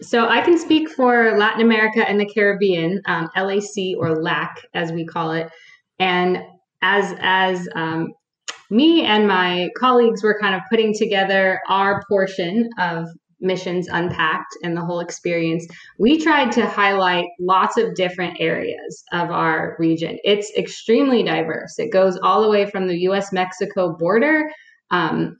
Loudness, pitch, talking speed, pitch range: -18 LUFS, 190 Hz, 155 wpm, 175-220 Hz